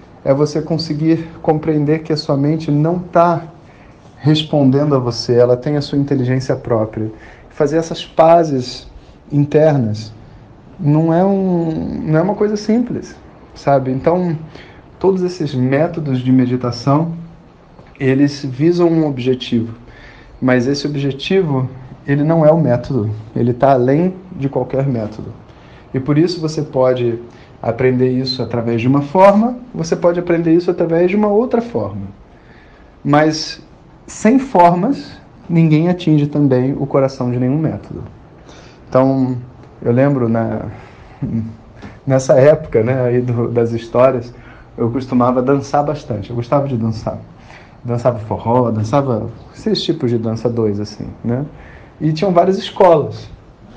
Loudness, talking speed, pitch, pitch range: -15 LUFS, 135 wpm, 140 Hz, 120-160 Hz